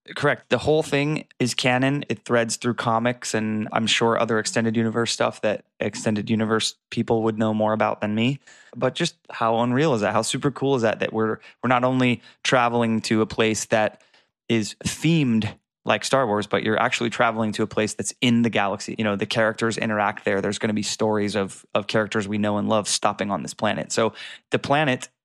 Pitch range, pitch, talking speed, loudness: 110-120 Hz, 115 Hz, 210 wpm, -23 LUFS